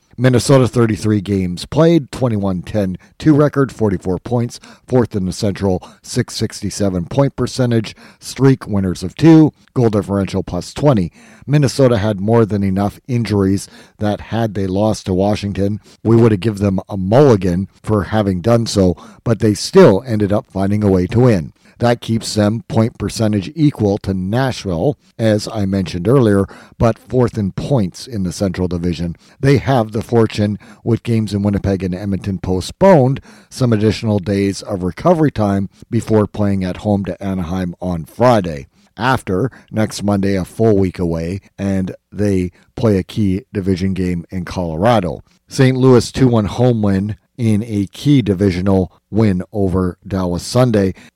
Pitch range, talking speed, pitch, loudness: 95-115 Hz, 155 wpm, 105 Hz, -16 LUFS